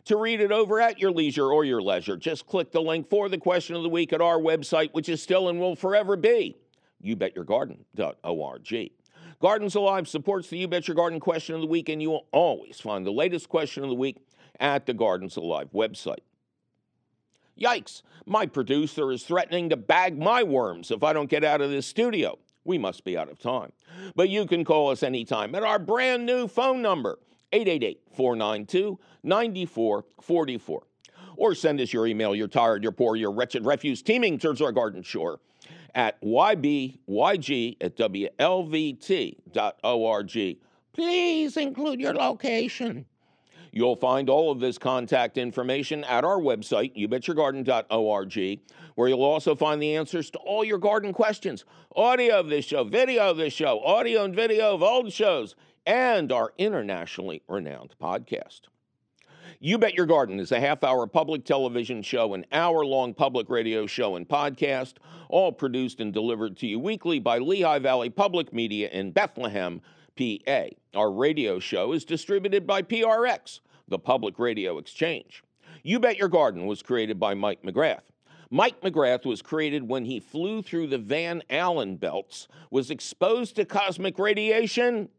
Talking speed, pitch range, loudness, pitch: 165 wpm, 135-205 Hz, -26 LUFS, 165 Hz